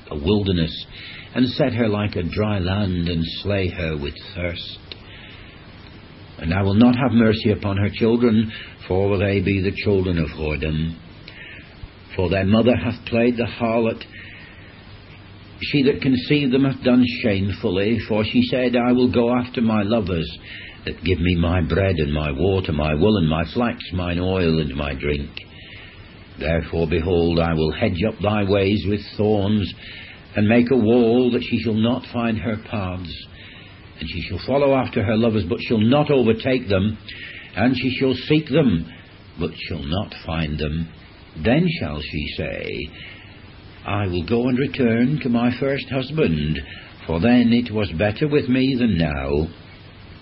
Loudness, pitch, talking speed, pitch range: -20 LUFS, 100 Hz, 165 wpm, 85-115 Hz